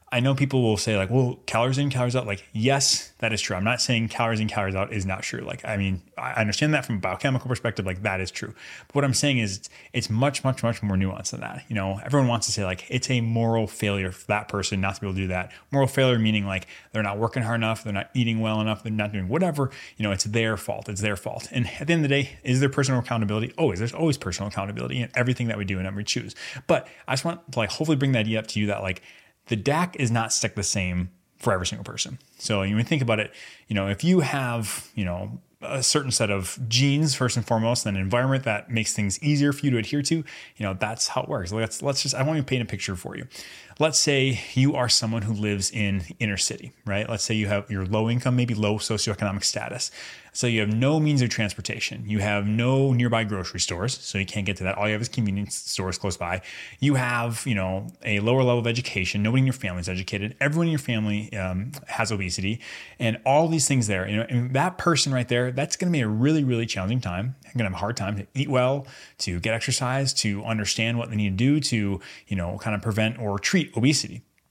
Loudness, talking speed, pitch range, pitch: -25 LUFS, 260 wpm, 100-130 Hz, 115 Hz